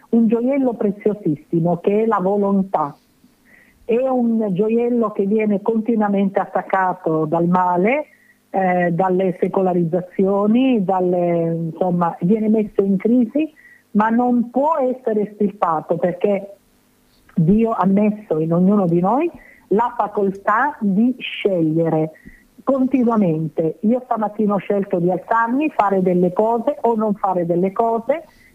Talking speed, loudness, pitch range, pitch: 120 wpm, -18 LUFS, 185-235 Hz, 205 Hz